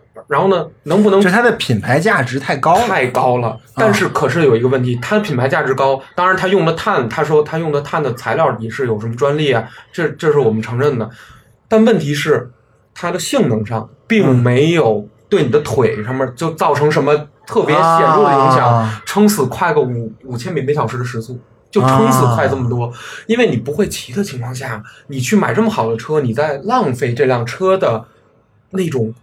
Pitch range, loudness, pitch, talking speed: 115-165 Hz, -15 LUFS, 135 Hz, 295 characters per minute